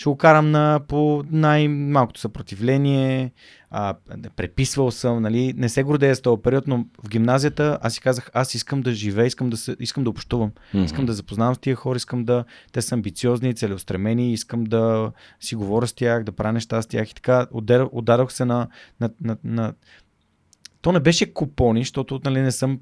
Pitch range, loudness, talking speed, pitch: 115-135 Hz, -21 LUFS, 190 wpm, 120 Hz